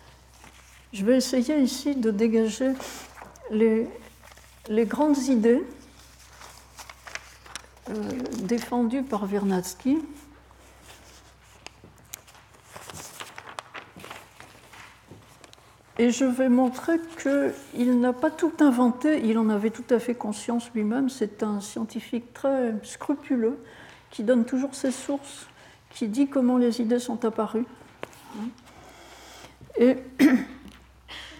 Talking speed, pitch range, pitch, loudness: 95 wpm, 225-270 Hz, 245 Hz, -25 LUFS